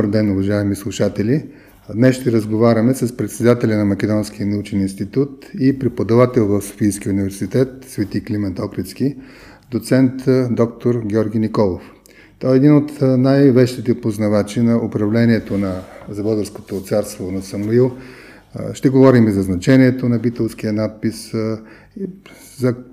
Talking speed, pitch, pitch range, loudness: 125 wpm, 110 Hz, 105-125 Hz, -17 LUFS